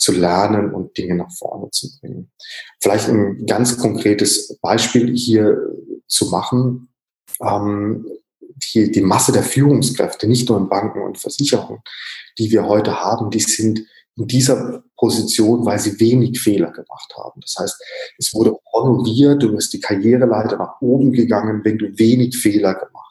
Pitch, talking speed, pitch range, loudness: 110 Hz, 155 wpm, 105-125 Hz, -16 LUFS